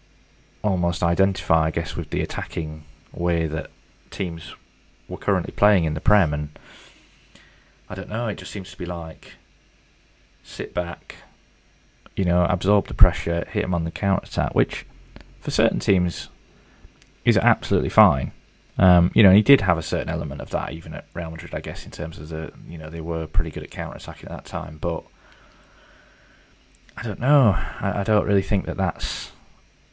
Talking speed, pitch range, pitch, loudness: 180 wpm, 80-100 Hz, 90 Hz, -23 LUFS